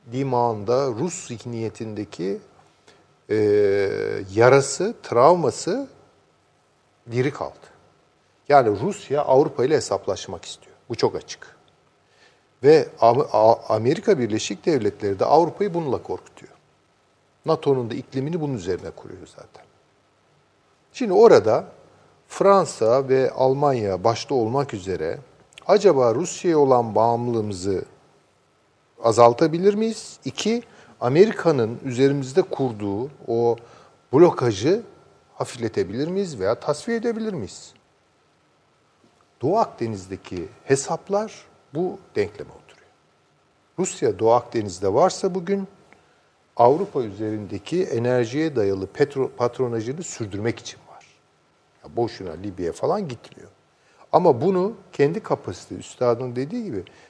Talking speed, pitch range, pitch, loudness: 95 wpm, 115-195 Hz, 135 Hz, -21 LUFS